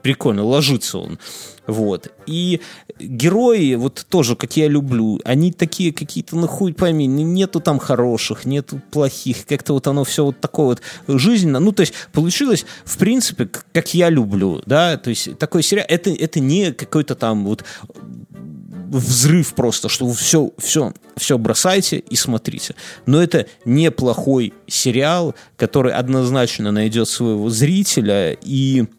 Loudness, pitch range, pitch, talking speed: -17 LUFS, 125-170 Hz, 145 Hz, 145 wpm